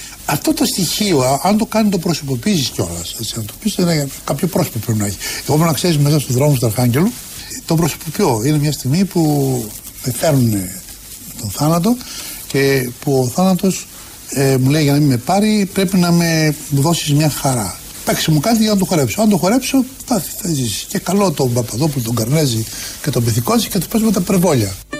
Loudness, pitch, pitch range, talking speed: -16 LUFS, 150 Hz, 125-190 Hz, 200 wpm